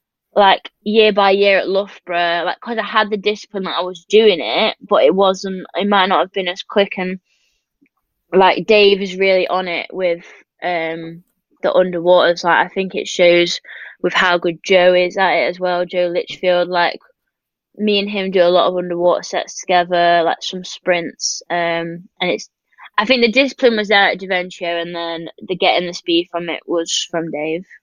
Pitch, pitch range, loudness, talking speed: 180 Hz, 175-200 Hz, -16 LUFS, 195 wpm